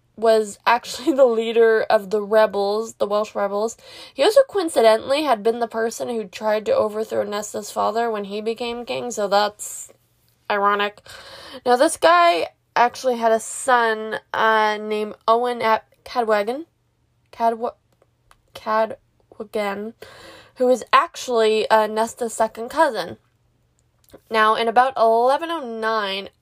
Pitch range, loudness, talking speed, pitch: 215-245 Hz, -20 LUFS, 125 wpm, 225 Hz